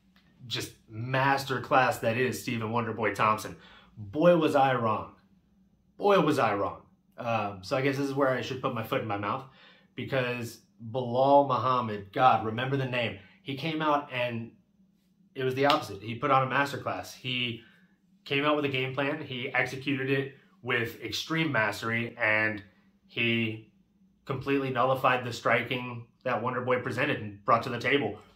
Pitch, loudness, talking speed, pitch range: 130 Hz, -28 LUFS, 165 wpm, 115-140 Hz